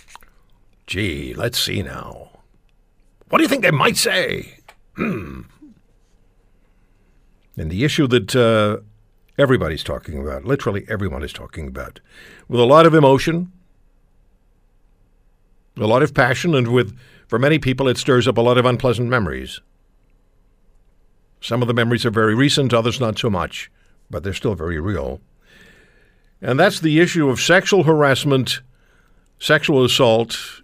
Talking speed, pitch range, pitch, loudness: 135 wpm, 100-135 Hz, 120 Hz, -17 LUFS